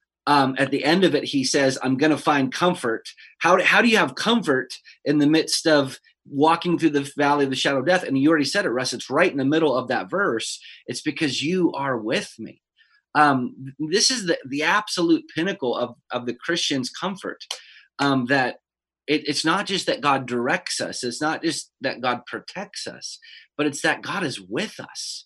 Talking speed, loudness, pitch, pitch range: 210 wpm, -22 LUFS, 150 Hz, 140-170 Hz